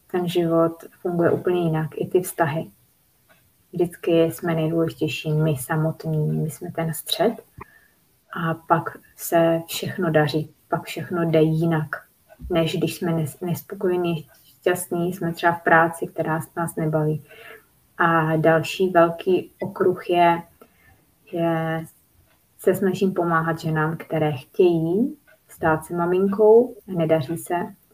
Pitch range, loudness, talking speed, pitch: 160-180 Hz, -22 LUFS, 120 wpm, 165 Hz